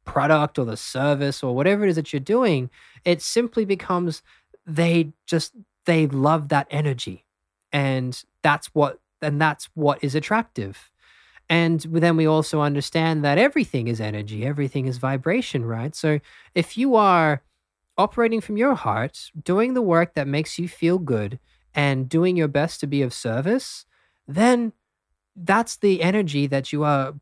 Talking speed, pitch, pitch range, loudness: 160 wpm, 155 Hz, 140-180 Hz, -22 LUFS